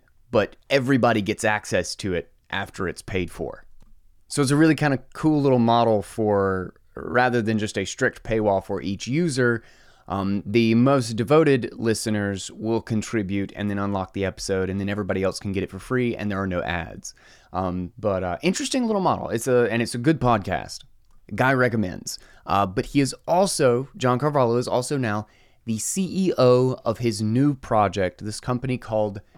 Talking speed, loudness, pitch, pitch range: 180 wpm, -23 LUFS, 115 Hz, 100-130 Hz